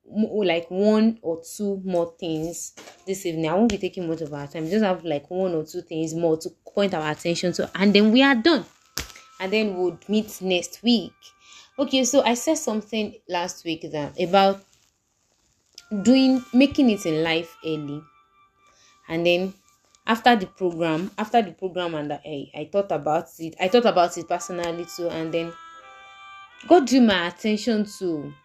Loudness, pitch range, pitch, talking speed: -23 LUFS, 165-215 Hz, 180 Hz, 175 wpm